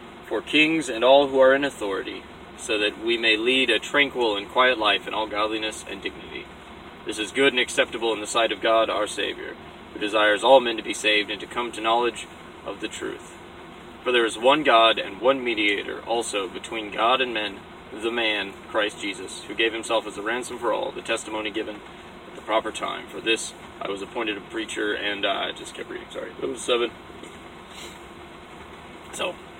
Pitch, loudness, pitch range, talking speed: 115 Hz, -23 LUFS, 110-130 Hz, 200 wpm